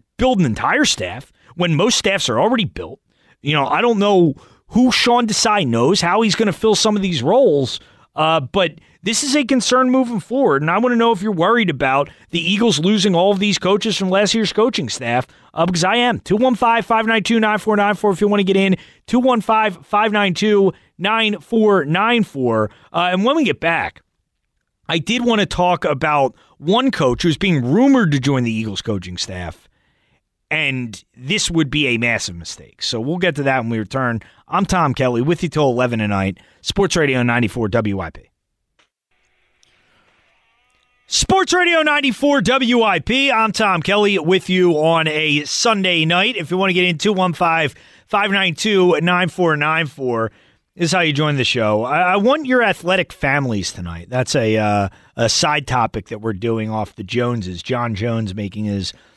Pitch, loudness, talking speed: 175 Hz, -17 LUFS, 175 wpm